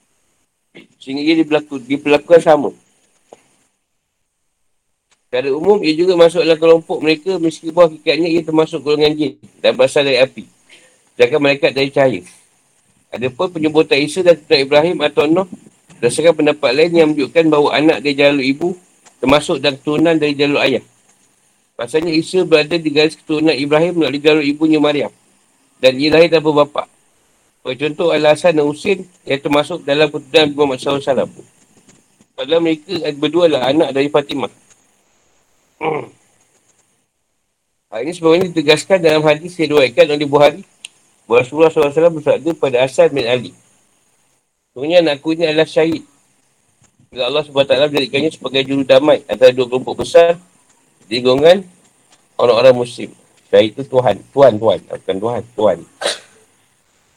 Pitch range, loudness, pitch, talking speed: 145-170 Hz, -14 LUFS, 155 Hz, 145 wpm